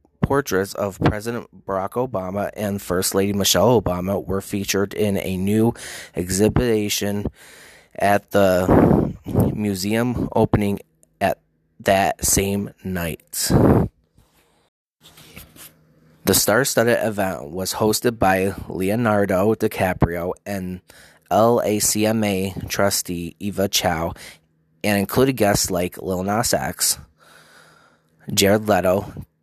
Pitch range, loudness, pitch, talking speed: 95-105 Hz, -20 LUFS, 100 Hz, 95 wpm